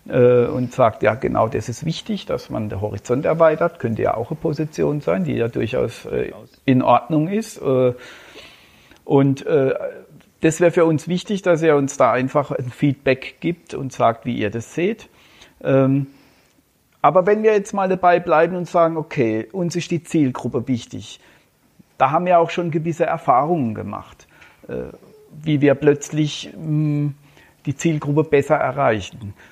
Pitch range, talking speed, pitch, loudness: 130-170 Hz, 150 wpm, 150 Hz, -19 LUFS